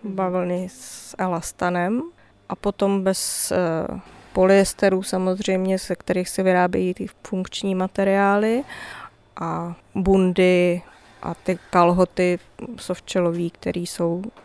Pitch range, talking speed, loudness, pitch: 180-195 Hz, 95 wpm, -22 LUFS, 185 Hz